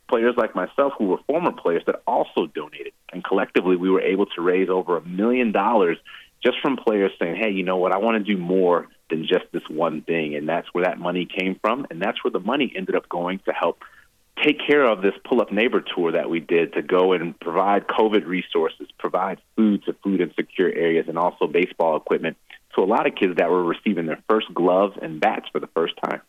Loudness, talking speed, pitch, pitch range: -22 LUFS, 230 wpm, 95 Hz, 90-110 Hz